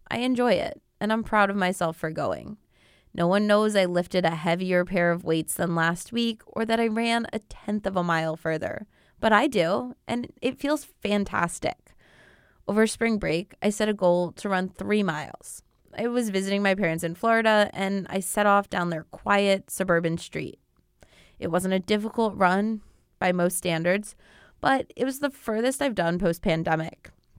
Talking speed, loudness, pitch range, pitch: 185 wpm, -25 LUFS, 175-220 Hz, 195 Hz